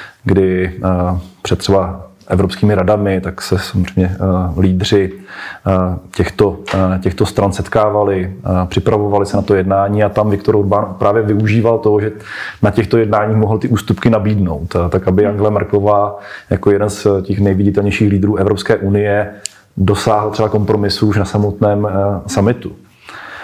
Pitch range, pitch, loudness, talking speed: 95-105 Hz, 100 Hz, -14 LUFS, 135 wpm